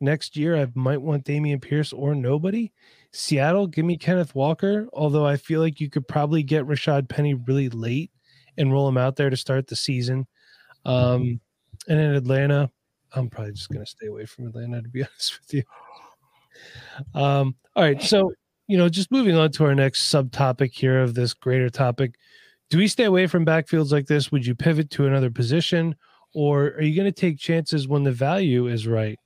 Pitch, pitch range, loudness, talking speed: 145 Hz, 130-160 Hz, -22 LUFS, 200 wpm